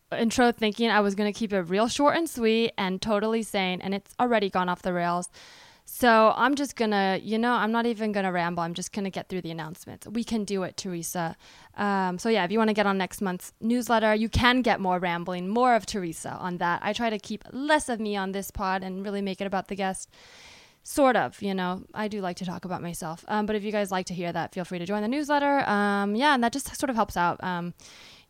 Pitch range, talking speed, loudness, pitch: 185-225 Hz, 260 wpm, -26 LUFS, 205 Hz